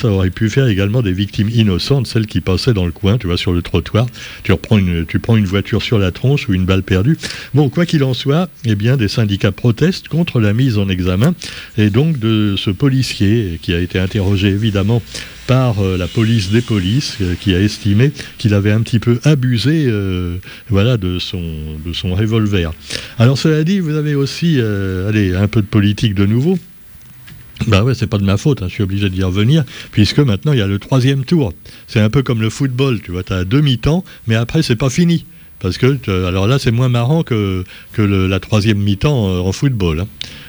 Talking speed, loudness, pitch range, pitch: 220 wpm, -15 LUFS, 95-130 Hz, 110 Hz